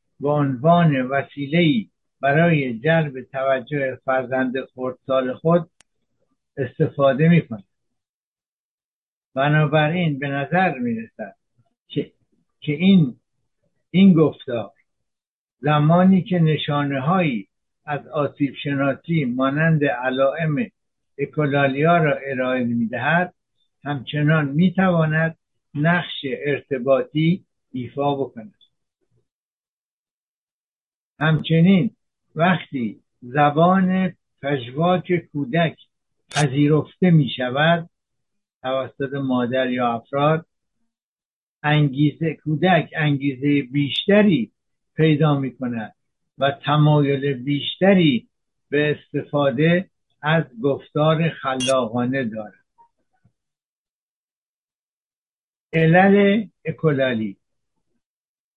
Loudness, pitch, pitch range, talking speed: -20 LUFS, 145 Hz, 135-165 Hz, 75 wpm